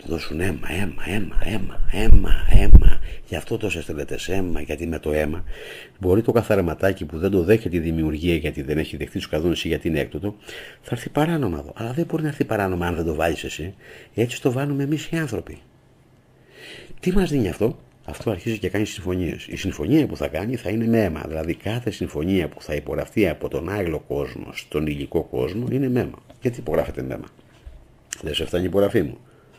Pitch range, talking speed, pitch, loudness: 80-115 Hz, 200 wpm, 90 Hz, -24 LUFS